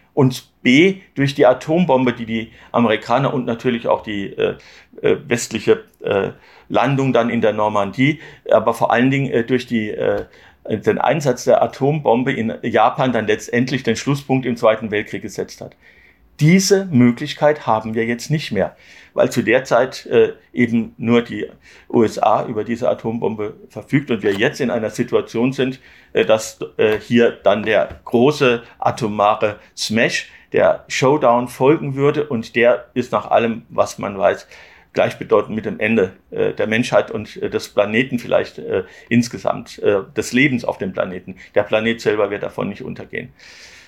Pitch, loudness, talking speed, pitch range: 120 Hz, -18 LUFS, 160 wpm, 115-140 Hz